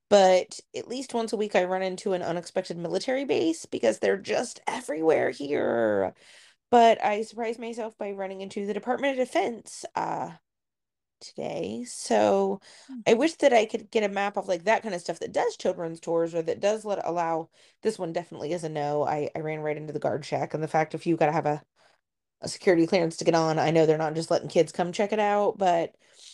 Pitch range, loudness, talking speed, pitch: 165-225 Hz, -27 LUFS, 215 wpm, 190 Hz